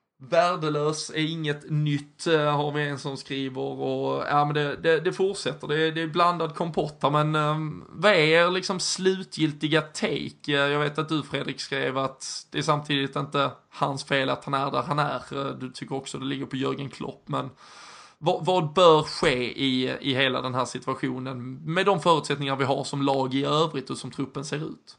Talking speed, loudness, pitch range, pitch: 195 wpm, -25 LUFS, 135-160 Hz, 145 Hz